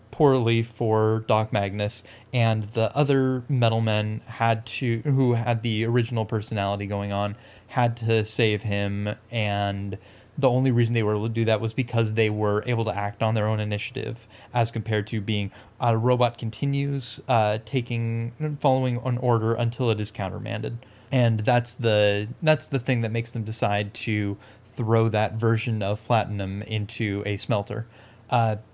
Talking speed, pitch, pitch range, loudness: 165 wpm, 115 Hz, 105-120 Hz, -25 LUFS